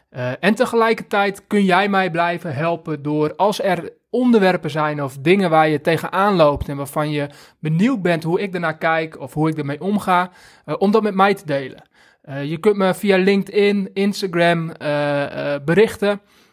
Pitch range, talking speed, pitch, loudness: 150-200 Hz, 180 wpm, 175 Hz, -18 LUFS